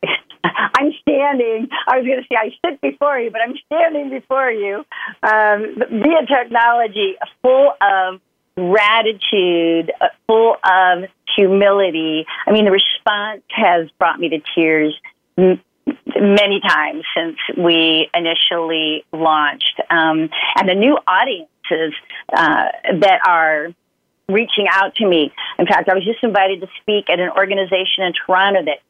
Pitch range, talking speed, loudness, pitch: 170-235 Hz, 135 wpm, -15 LUFS, 195 Hz